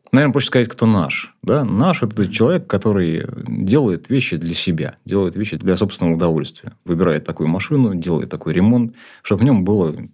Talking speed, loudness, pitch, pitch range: 180 wpm, -18 LUFS, 105 Hz, 85-120 Hz